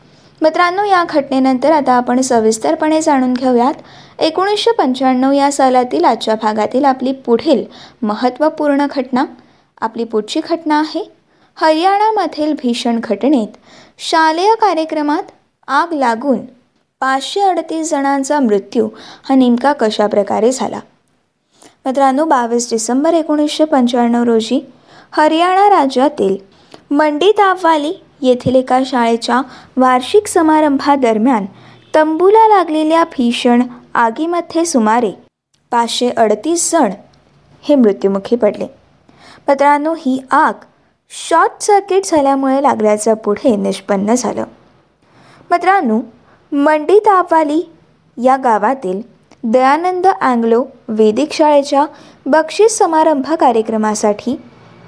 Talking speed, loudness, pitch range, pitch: 90 wpm, -13 LUFS, 235-315 Hz, 275 Hz